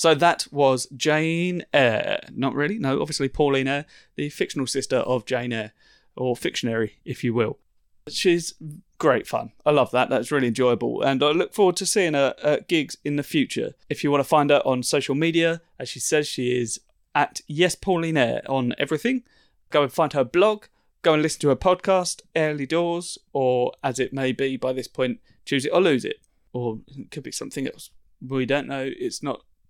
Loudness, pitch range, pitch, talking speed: -23 LUFS, 130-165 Hz, 145 Hz, 200 wpm